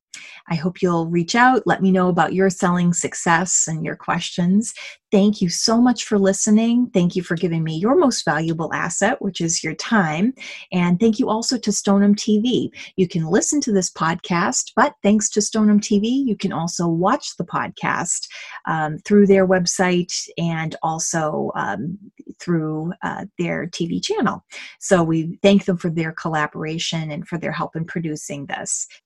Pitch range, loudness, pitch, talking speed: 165-210 Hz, -19 LUFS, 185 Hz, 175 wpm